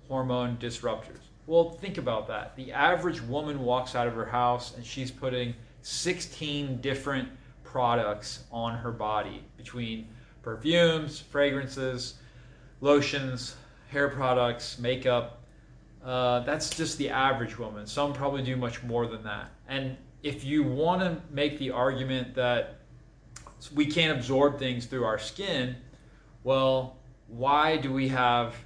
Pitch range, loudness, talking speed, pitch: 120-140 Hz, -29 LUFS, 135 wpm, 130 Hz